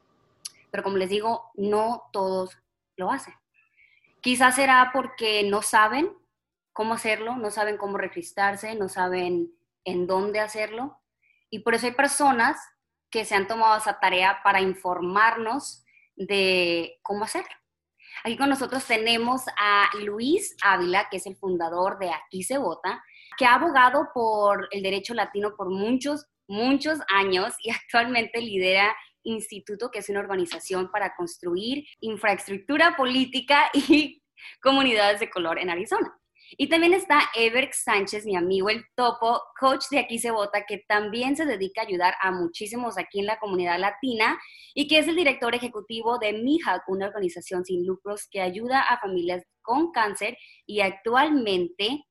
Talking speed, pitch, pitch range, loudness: 150 wpm, 215 Hz, 195-255 Hz, -24 LUFS